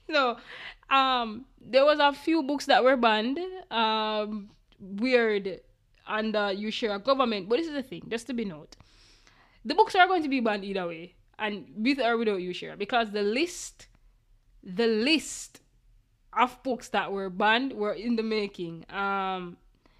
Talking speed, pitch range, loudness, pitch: 175 wpm, 195-255 Hz, -27 LUFS, 220 Hz